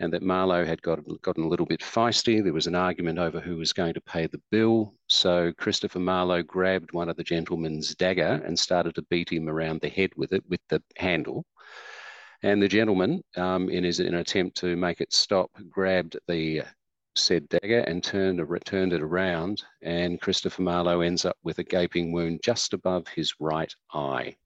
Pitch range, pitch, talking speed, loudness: 85-95 Hz, 90 Hz, 195 wpm, -26 LUFS